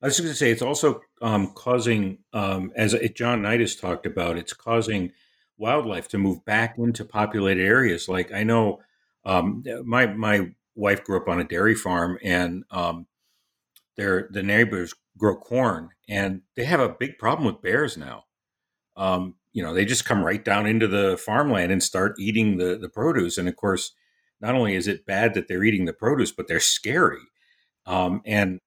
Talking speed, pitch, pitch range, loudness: 190 wpm, 100 Hz, 95-115 Hz, -23 LUFS